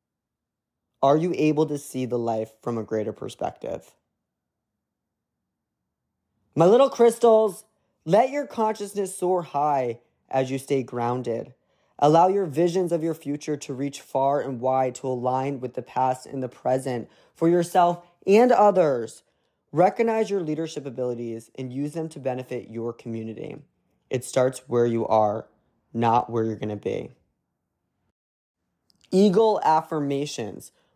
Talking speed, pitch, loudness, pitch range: 135 wpm, 135 Hz, -24 LUFS, 120-170 Hz